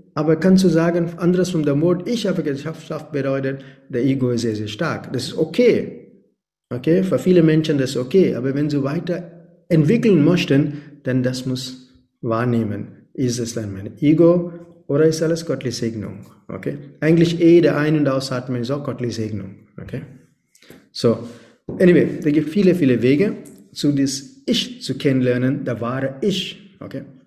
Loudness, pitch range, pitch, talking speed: -19 LUFS, 125-170 Hz, 145 Hz, 165 wpm